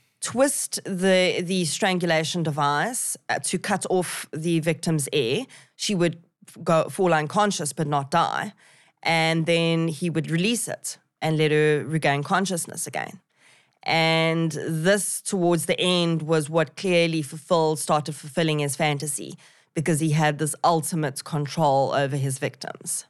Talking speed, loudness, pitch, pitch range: 140 wpm, -23 LUFS, 165 Hz, 155-175 Hz